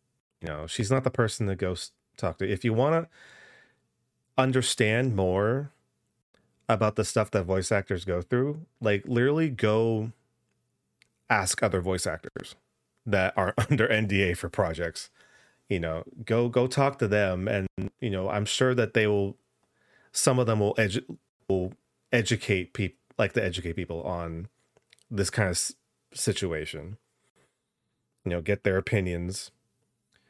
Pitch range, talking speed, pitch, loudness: 95-120 Hz, 145 wpm, 105 Hz, -27 LUFS